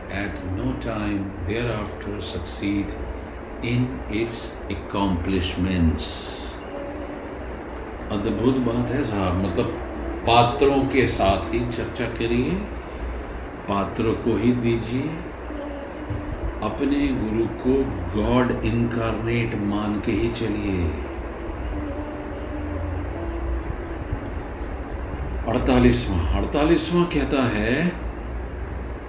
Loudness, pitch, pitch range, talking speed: -25 LUFS, 100 Hz, 85-115 Hz, 75 wpm